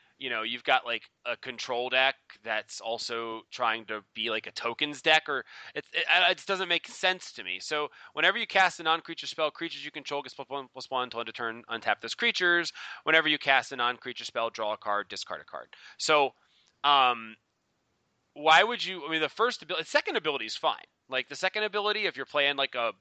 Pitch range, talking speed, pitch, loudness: 115-175 Hz, 225 wpm, 145 Hz, -28 LUFS